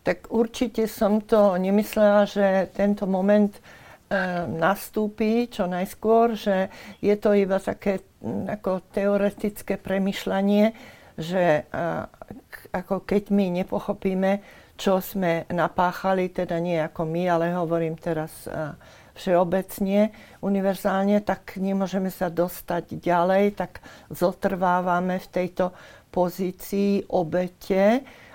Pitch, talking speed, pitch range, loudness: 195 Hz, 100 wpm, 180-205 Hz, -24 LUFS